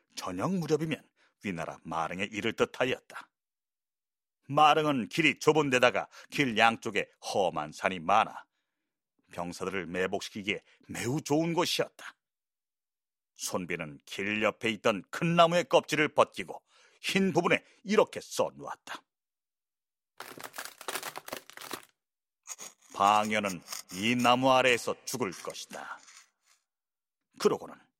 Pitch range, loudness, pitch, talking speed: 105-165 Hz, -29 LUFS, 140 Hz, 225 characters per minute